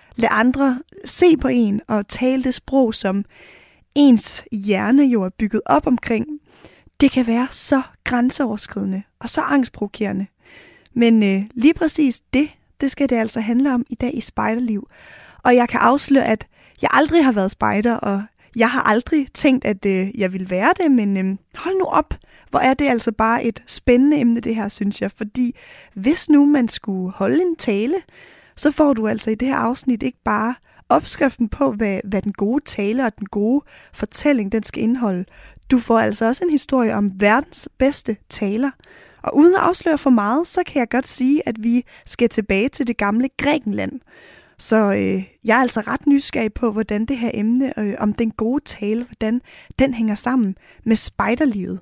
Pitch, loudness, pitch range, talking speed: 240 Hz, -19 LUFS, 215-275 Hz, 185 wpm